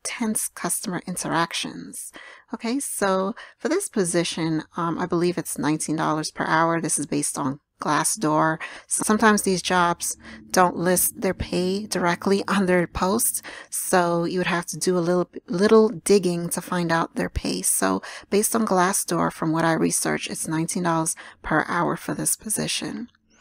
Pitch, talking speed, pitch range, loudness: 180 Hz, 155 wpm, 160-195 Hz, -23 LUFS